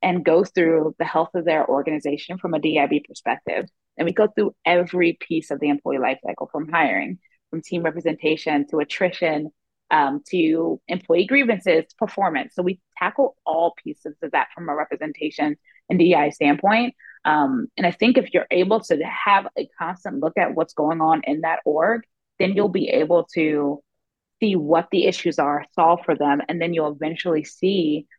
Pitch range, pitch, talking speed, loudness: 155-185 Hz, 165 Hz, 185 wpm, -21 LUFS